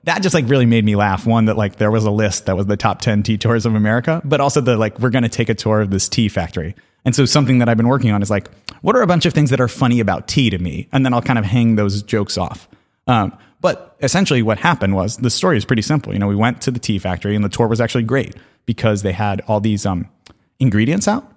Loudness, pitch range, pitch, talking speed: -16 LUFS, 105-130 Hz, 115 Hz, 285 wpm